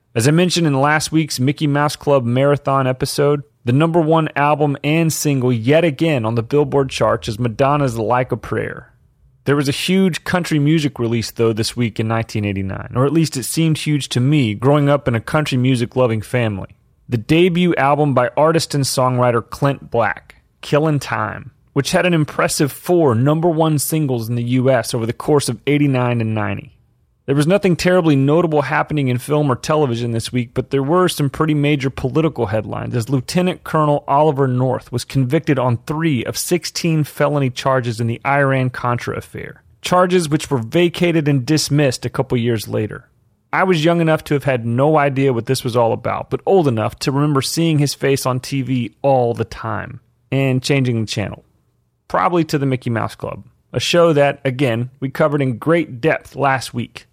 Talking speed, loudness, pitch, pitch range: 190 wpm, -17 LUFS, 135 Hz, 120-150 Hz